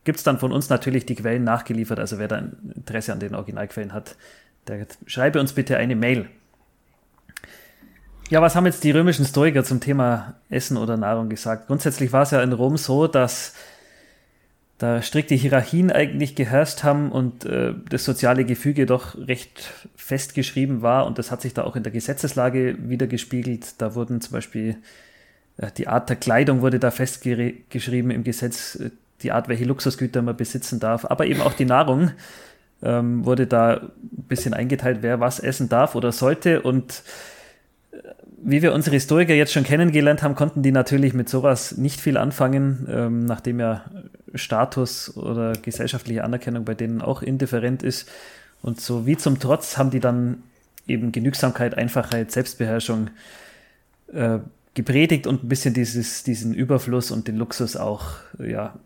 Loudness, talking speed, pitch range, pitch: -22 LUFS, 165 wpm, 120-135 Hz, 125 Hz